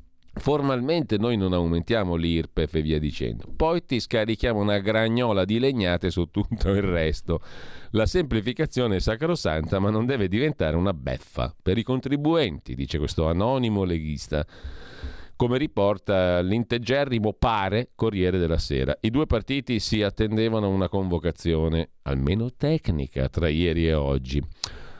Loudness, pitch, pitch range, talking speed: -25 LUFS, 100 Hz, 80-115 Hz, 135 wpm